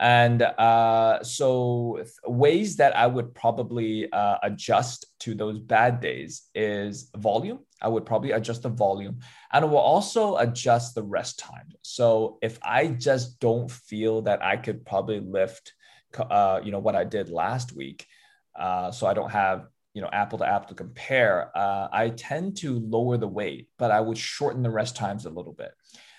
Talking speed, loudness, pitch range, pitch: 180 wpm, -25 LUFS, 105-125 Hz, 115 Hz